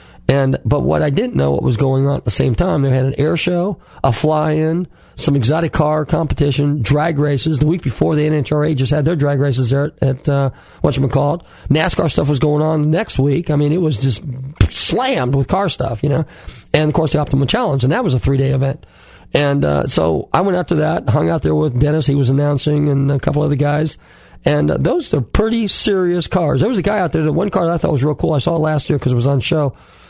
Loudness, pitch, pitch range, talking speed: -16 LUFS, 145 Hz, 135-155 Hz, 255 wpm